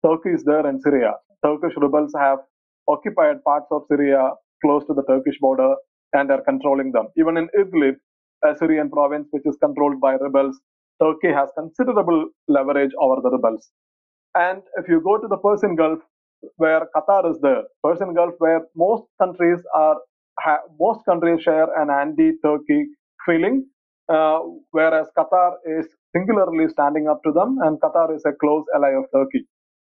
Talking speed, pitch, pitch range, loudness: 160 wpm, 155 Hz, 145-175 Hz, -19 LUFS